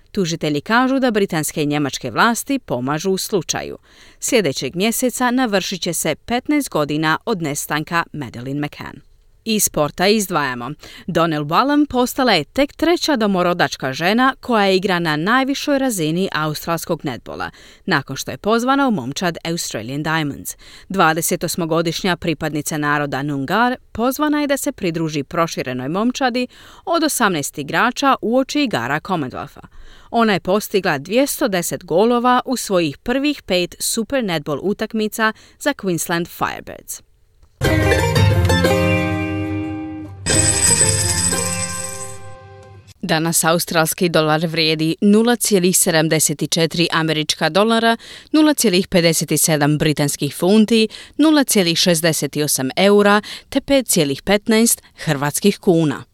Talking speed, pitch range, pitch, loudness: 105 wpm, 150-225 Hz, 170 Hz, -17 LUFS